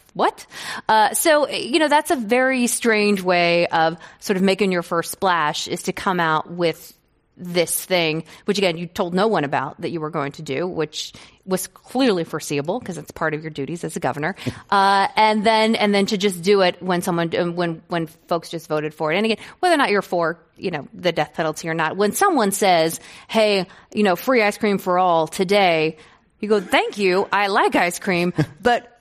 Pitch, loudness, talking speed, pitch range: 180 Hz, -20 LUFS, 215 wpm, 165-210 Hz